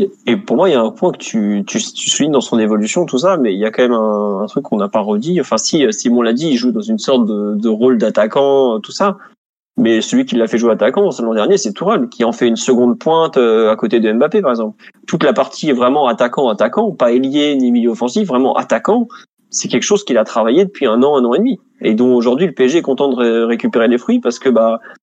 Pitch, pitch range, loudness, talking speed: 125 Hz, 115-190 Hz, -14 LUFS, 270 wpm